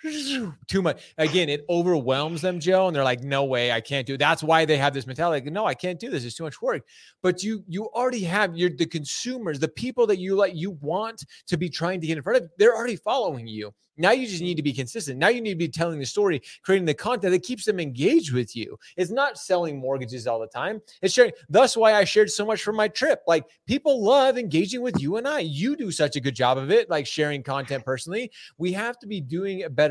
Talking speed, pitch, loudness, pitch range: 255 wpm, 175 Hz, -24 LUFS, 145-215 Hz